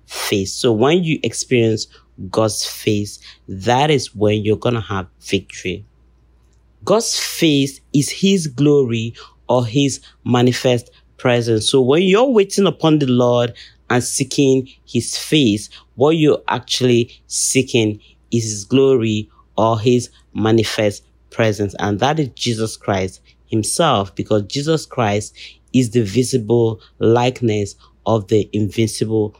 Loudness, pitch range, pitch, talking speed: -17 LUFS, 105-130 Hz, 115 Hz, 125 wpm